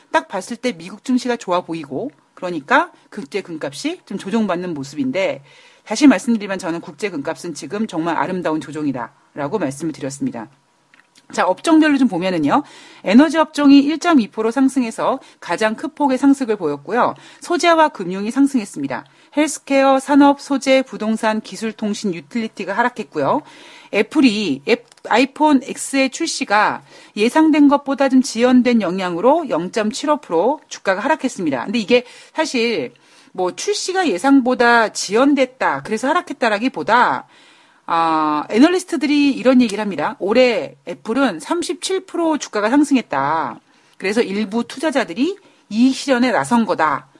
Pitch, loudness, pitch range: 255 Hz, -17 LUFS, 210-290 Hz